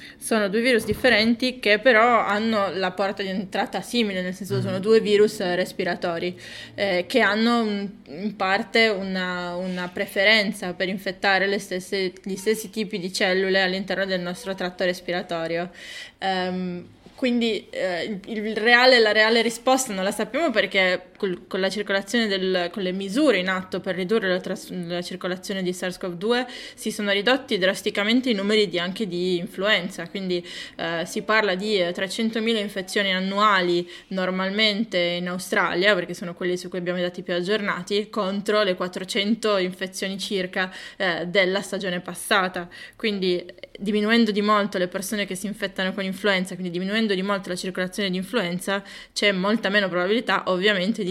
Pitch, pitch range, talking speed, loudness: 195 Hz, 185-215 Hz, 160 wpm, -23 LUFS